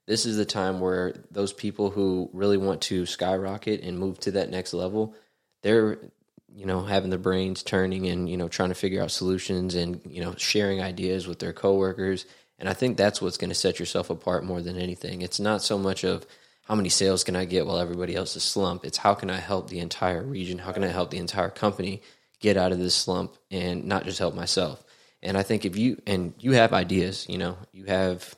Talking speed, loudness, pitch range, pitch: 230 wpm, -27 LUFS, 90-100 Hz, 95 Hz